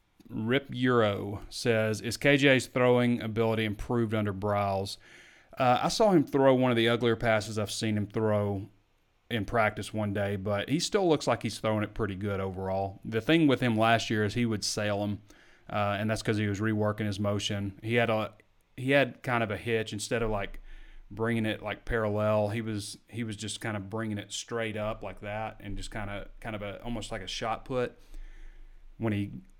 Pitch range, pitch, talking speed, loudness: 105-115 Hz, 110 Hz, 205 wpm, -29 LUFS